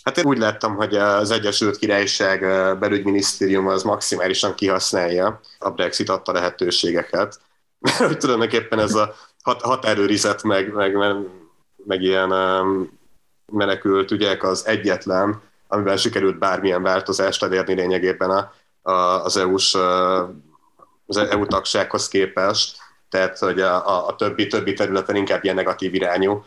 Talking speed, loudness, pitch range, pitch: 125 wpm, -20 LUFS, 95-105 Hz, 95 Hz